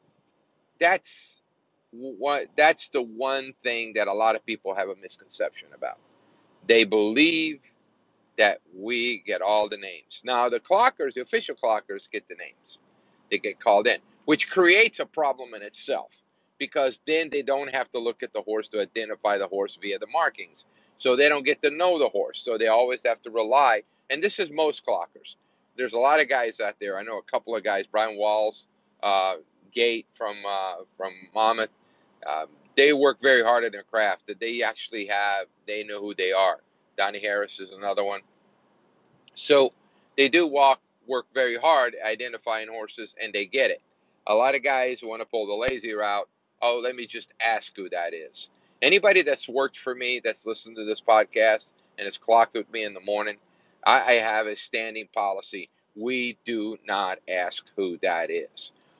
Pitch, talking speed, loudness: 125 Hz, 185 wpm, -24 LUFS